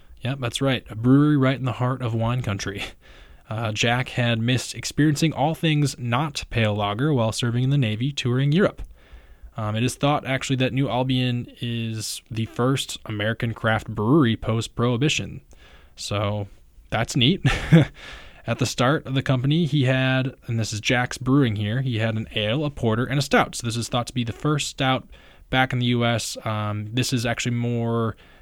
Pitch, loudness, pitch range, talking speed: 120 Hz, -23 LUFS, 110-135 Hz, 190 wpm